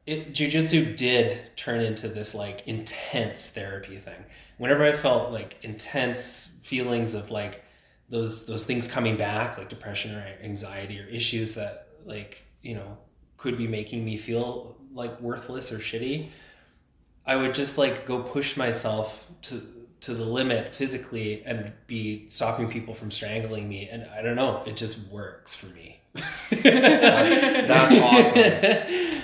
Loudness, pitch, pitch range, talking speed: -24 LUFS, 115 Hz, 110-130 Hz, 150 wpm